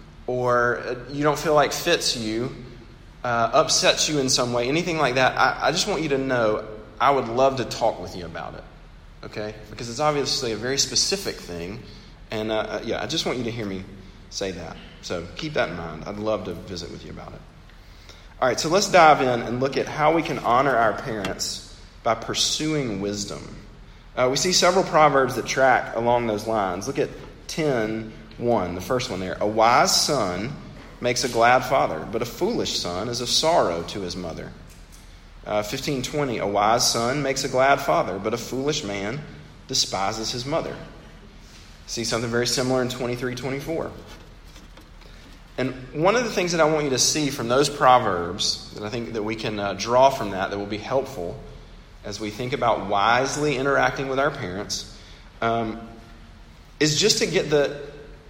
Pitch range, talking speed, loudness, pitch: 105-135 Hz, 190 wpm, -22 LUFS, 120 Hz